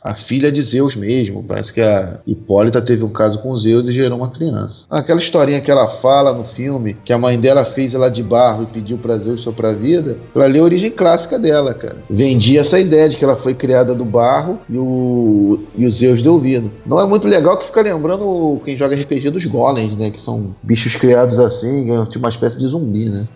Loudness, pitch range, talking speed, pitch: -14 LUFS, 115-140 Hz, 225 wpm, 125 Hz